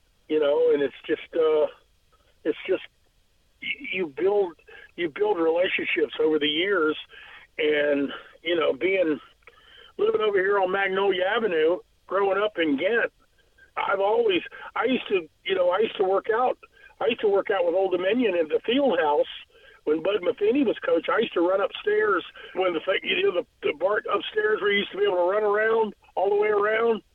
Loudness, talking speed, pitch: -24 LUFS, 190 wpm, 395 Hz